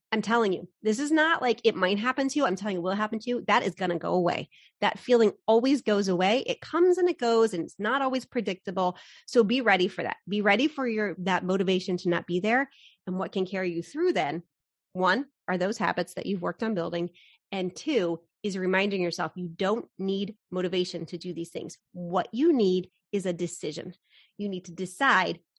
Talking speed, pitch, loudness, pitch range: 225 wpm, 195 Hz, -27 LUFS, 180-230 Hz